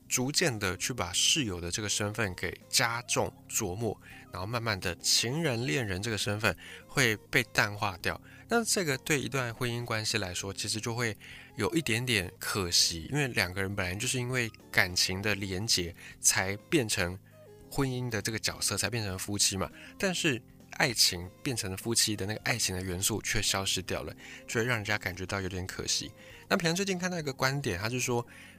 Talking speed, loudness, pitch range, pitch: 285 characters per minute, -30 LUFS, 95-125 Hz, 110 Hz